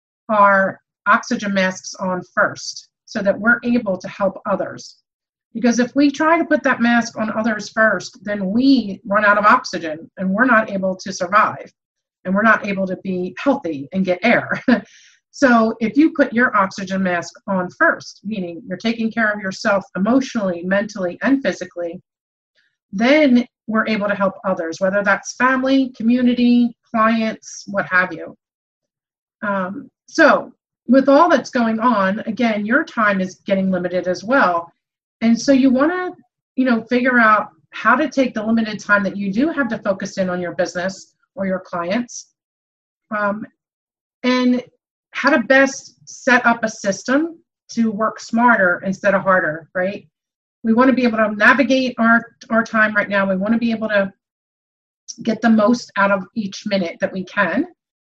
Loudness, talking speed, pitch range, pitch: -17 LUFS, 170 wpm, 190-245 Hz, 215 Hz